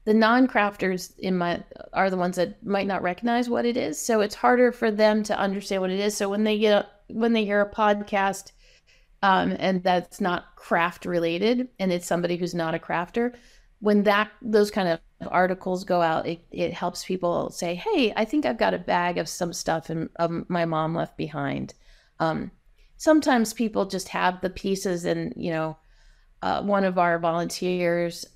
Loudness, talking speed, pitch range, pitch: -25 LUFS, 195 wpm, 175-215 Hz, 190 Hz